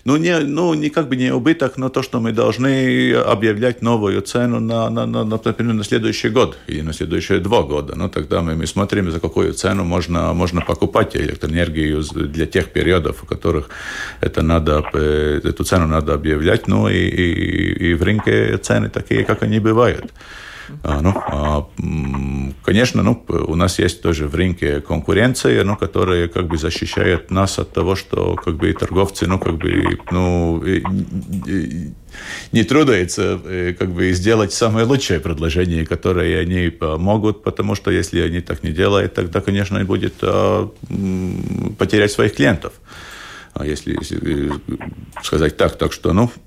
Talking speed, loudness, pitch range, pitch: 160 wpm, -18 LUFS, 85-110 Hz, 95 Hz